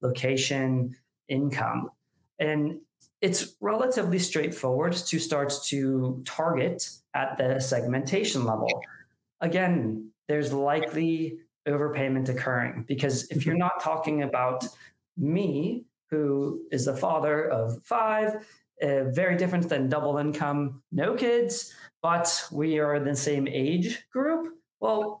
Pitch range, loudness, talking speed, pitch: 135-170 Hz, -27 LUFS, 115 wpm, 150 Hz